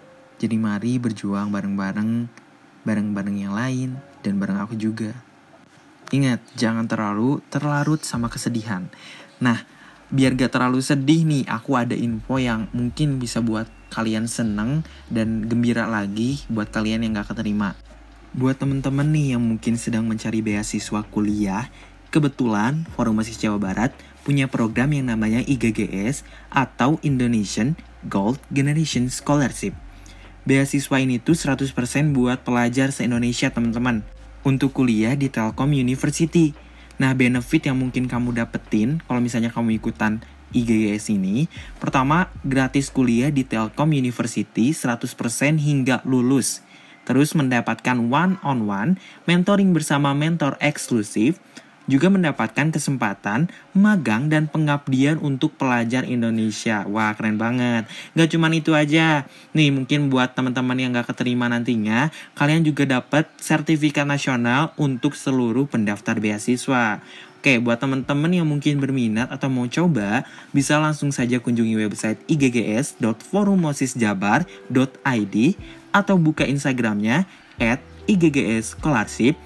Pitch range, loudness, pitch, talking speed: 110-145 Hz, -21 LUFS, 125 Hz, 120 wpm